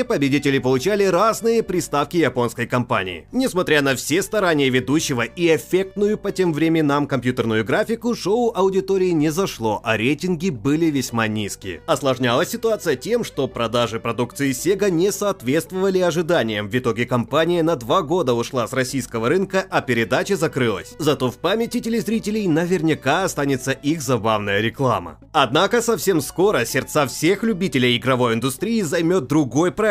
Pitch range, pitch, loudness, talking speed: 125-190 Hz, 150 Hz, -20 LUFS, 140 wpm